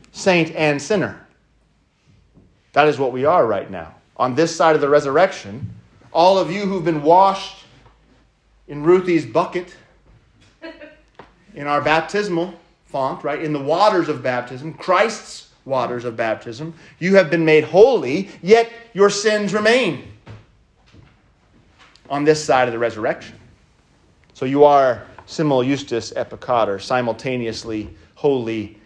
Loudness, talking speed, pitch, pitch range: -18 LUFS, 130 wpm, 155 Hz, 130-185 Hz